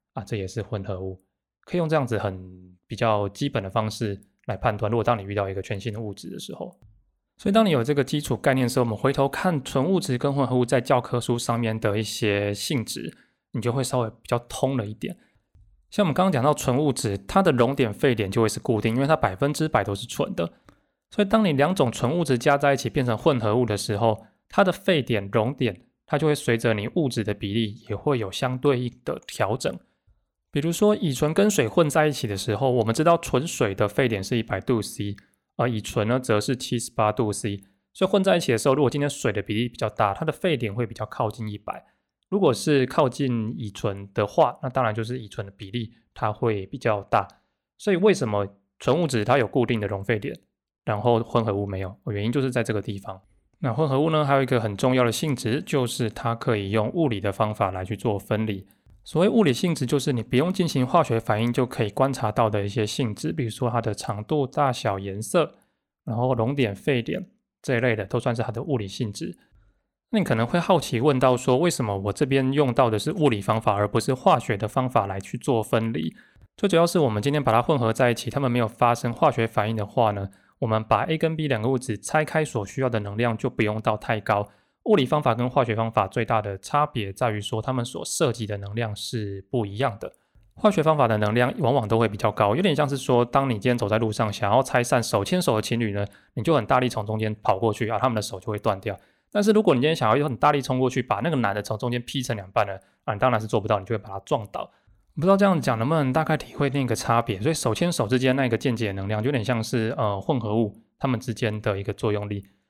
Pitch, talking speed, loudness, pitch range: 120 Hz, 345 characters per minute, -24 LUFS, 105-135 Hz